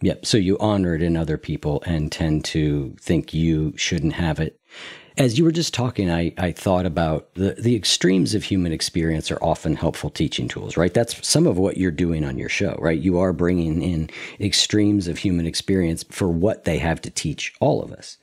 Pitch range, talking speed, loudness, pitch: 80-100 Hz, 210 wpm, -21 LUFS, 85 Hz